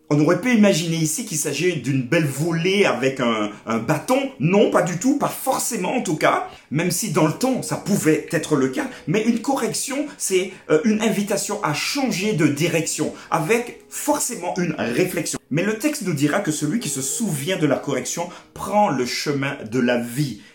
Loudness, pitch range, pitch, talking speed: -21 LUFS, 150-215 Hz, 170 Hz, 195 wpm